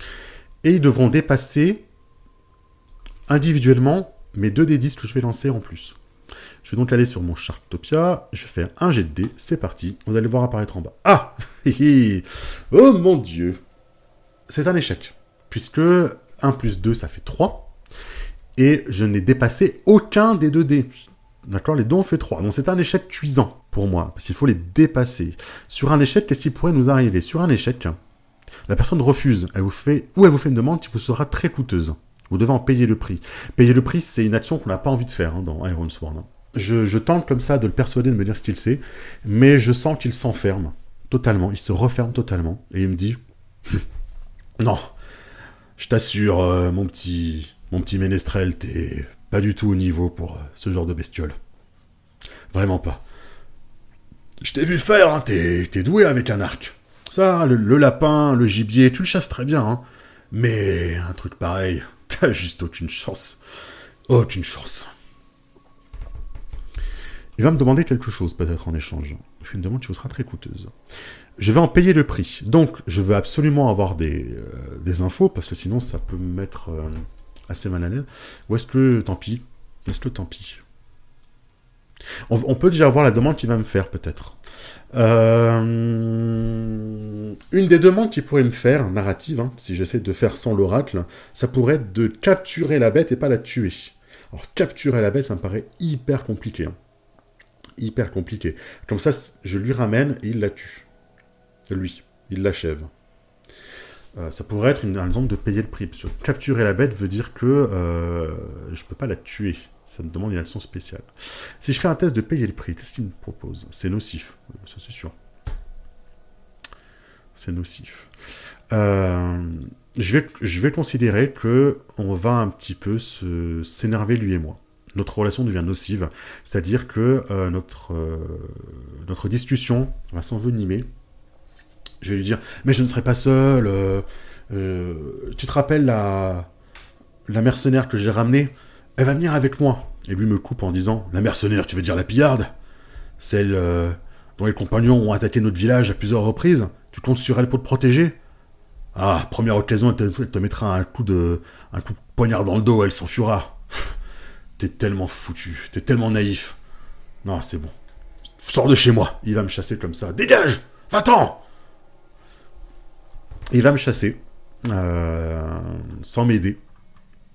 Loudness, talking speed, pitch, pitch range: -20 LUFS, 185 wpm, 110 Hz, 90-130 Hz